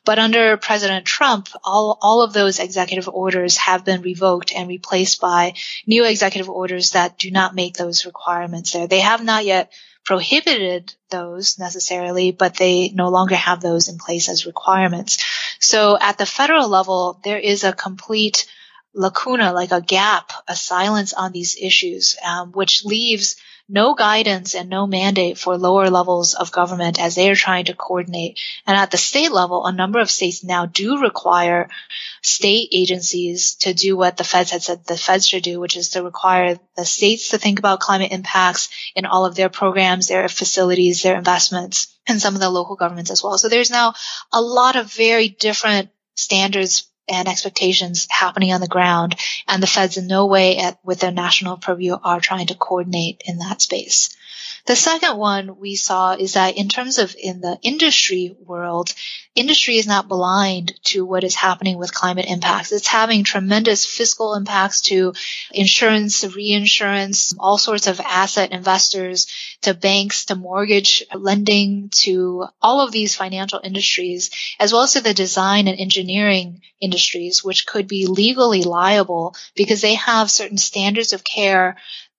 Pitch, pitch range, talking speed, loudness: 190 Hz, 180-205 Hz, 175 wpm, -16 LUFS